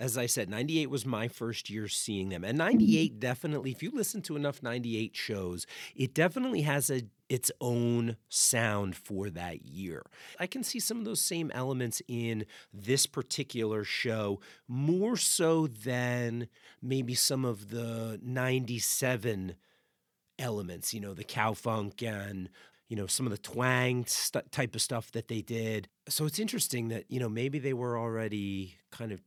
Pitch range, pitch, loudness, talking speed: 110-135 Hz, 120 Hz, -32 LUFS, 170 wpm